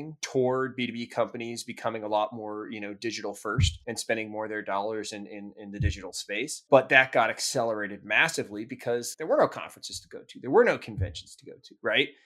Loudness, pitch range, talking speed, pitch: -28 LUFS, 100-120 Hz, 215 wpm, 110 Hz